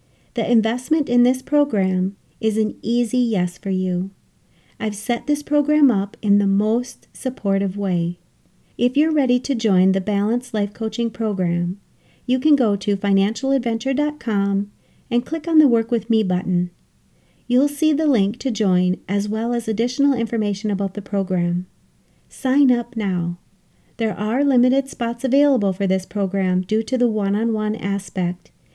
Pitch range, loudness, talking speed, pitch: 195-250 Hz, -20 LUFS, 160 wpm, 220 Hz